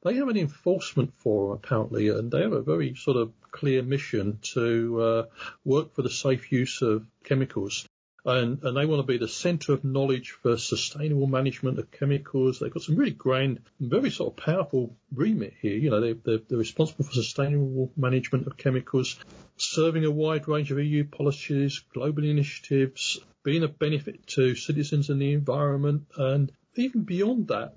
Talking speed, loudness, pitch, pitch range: 180 wpm, -27 LUFS, 140 Hz, 130-150 Hz